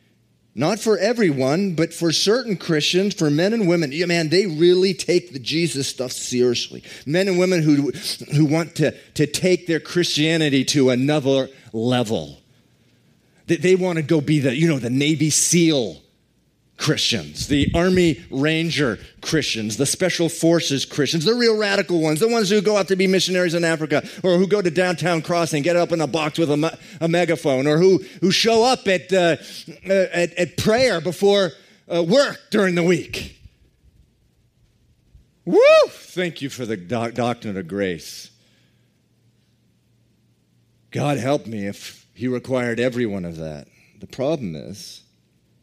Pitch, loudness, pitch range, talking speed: 165 Hz, -19 LUFS, 135-180 Hz, 160 wpm